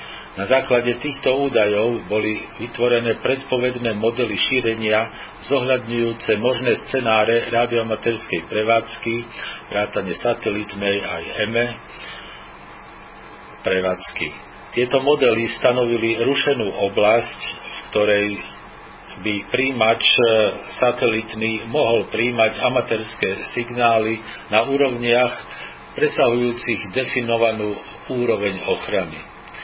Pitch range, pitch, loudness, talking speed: 110-125 Hz, 115 Hz, -20 LUFS, 80 wpm